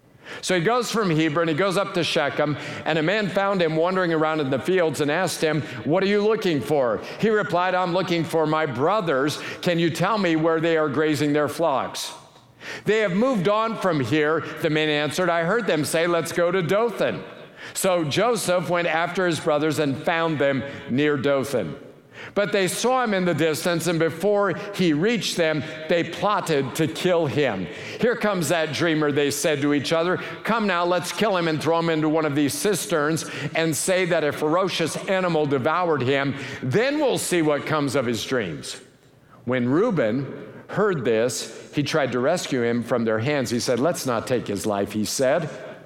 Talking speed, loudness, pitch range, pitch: 195 wpm, -22 LUFS, 150-185 Hz, 165 Hz